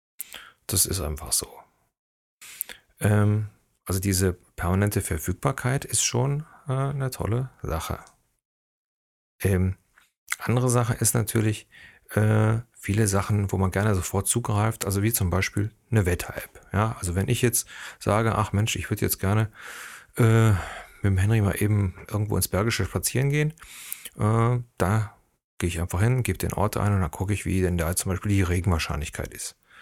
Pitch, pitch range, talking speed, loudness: 105 Hz, 95-115 Hz, 160 wpm, -25 LUFS